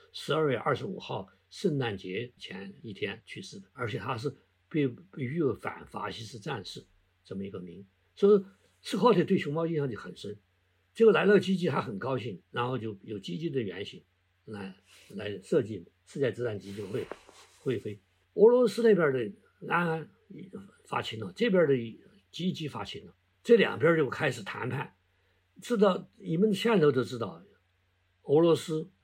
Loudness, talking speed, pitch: -29 LUFS, 245 characters per minute, 125 Hz